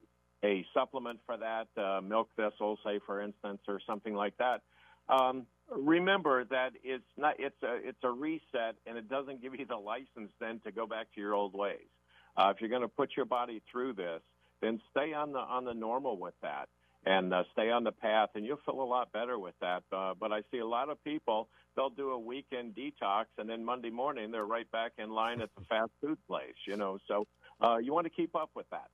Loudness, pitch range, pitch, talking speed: -36 LUFS, 105-130 Hz, 115 Hz, 220 wpm